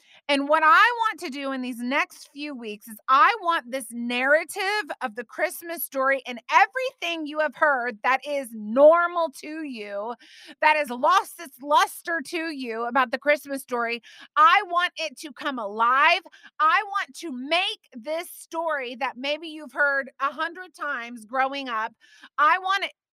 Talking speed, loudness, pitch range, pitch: 170 wpm, -23 LUFS, 260-335 Hz, 295 Hz